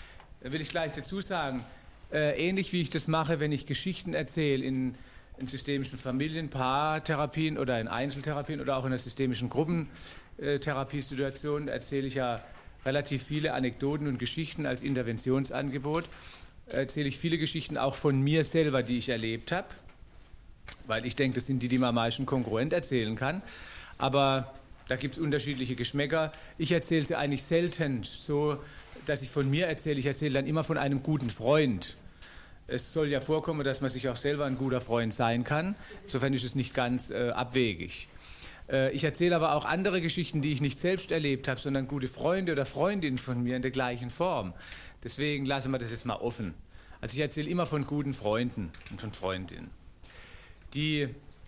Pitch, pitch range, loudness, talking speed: 135 Hz, 125-150 Hz, -30 LUFS, 175 wpm